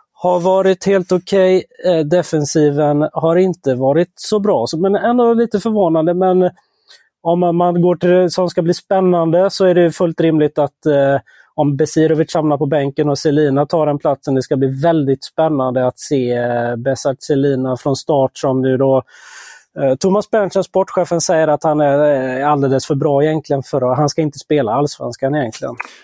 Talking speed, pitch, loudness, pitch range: 175 wpm, 155 Hz, -15 LUFS, 140-180 Hz